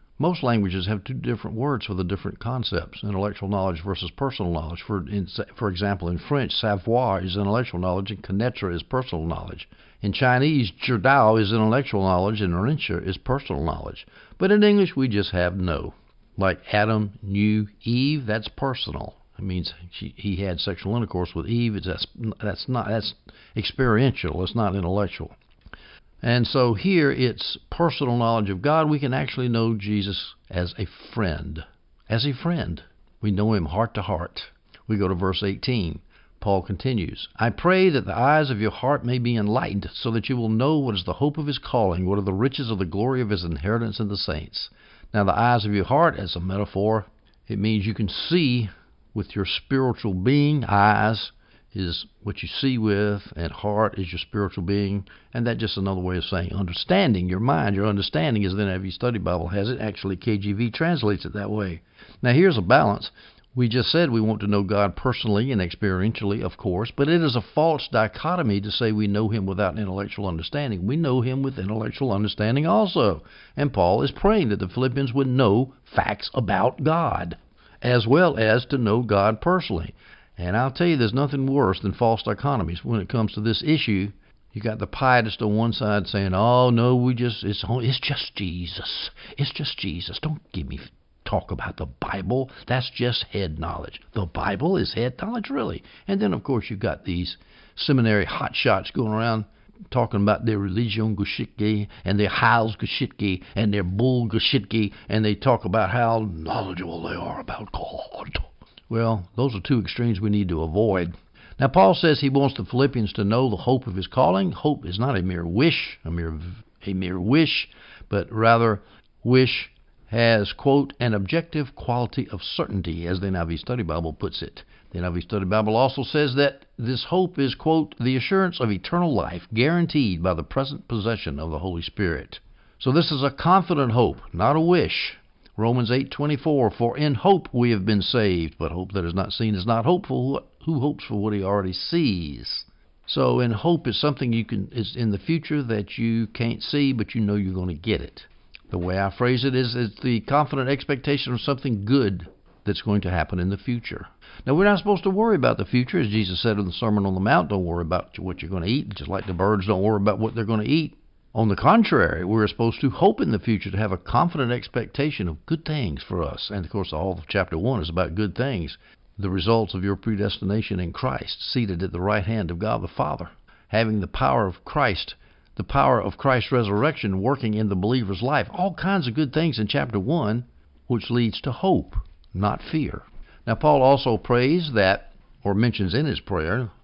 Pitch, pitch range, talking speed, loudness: 110 Hz, 95-130 Hz, 195 wpm, -23 LUFS